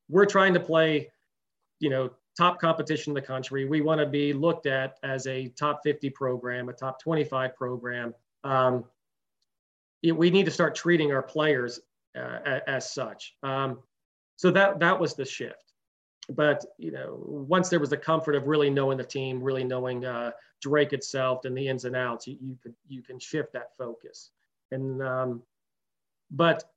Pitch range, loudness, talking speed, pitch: 130-155 Hz, -27 LUFS, 175 wpm, 135 Hz